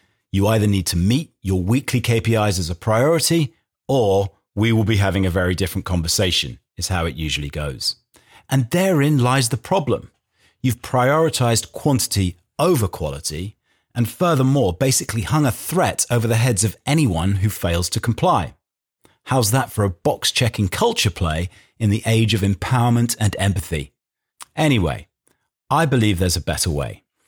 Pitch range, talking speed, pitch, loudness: 95-125 Hz, 155 wpm, 110 Hz, -19 LUFS